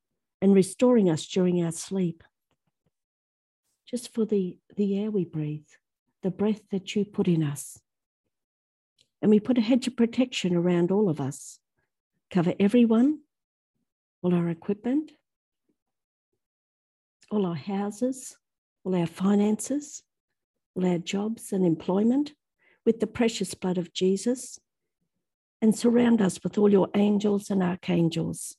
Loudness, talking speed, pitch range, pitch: -26 LUFS, 130 wpm, 180-230 Hz, 200 Hz